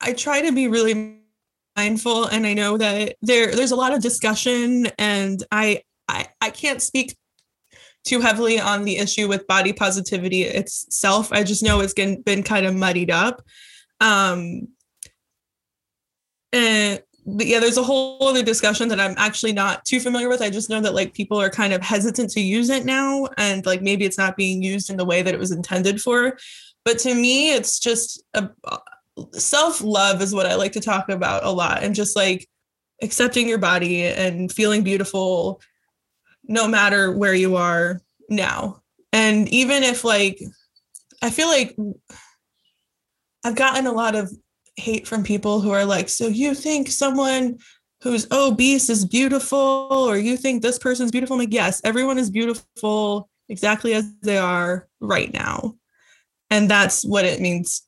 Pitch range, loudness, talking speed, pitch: 200-245 Hz, -19 LUFS, 170 wpm, 215 Hz